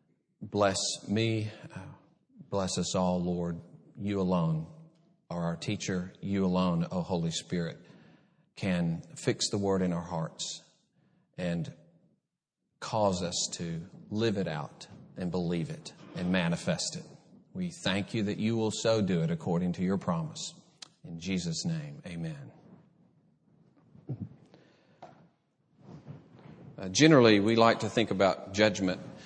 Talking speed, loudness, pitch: 125 wpm, -30 LUFS, 110 Hz